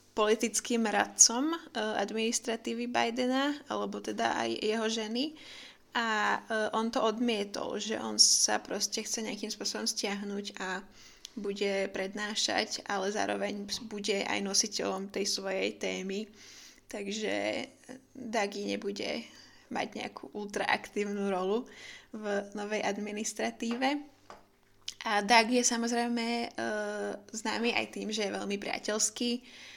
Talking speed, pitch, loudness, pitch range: 105 wpm, 215 Hz, -31 LUFS, 200-230 Hz